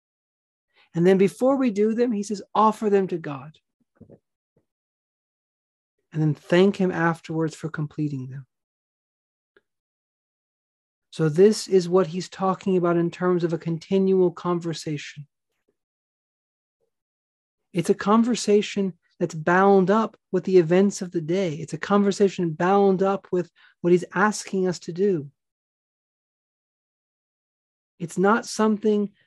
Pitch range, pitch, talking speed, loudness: 170-200 Hz, 185 Hz, 125 wpm, -22 LUFS